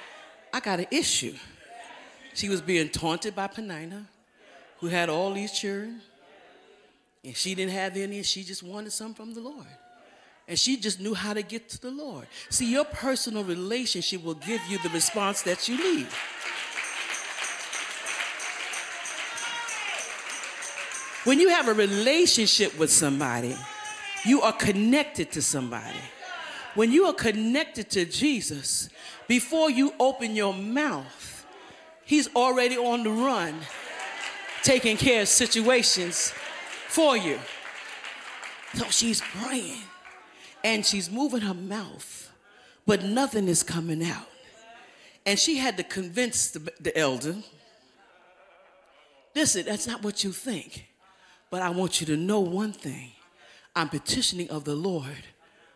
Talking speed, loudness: 130 wpm, -26 LUFS